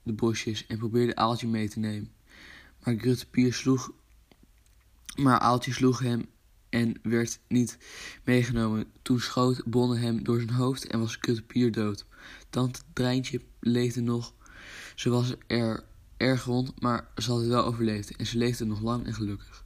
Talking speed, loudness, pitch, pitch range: 155 wpm, -28 LUFS, 120 Hz, 115-125 Hz